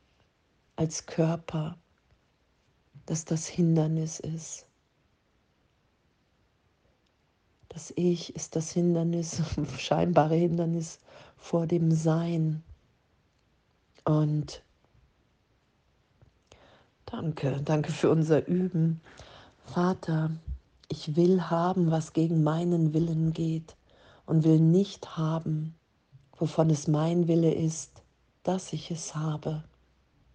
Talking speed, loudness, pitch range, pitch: 85 wpm, -28 LUFS, 155-170 Hz, 160 Hz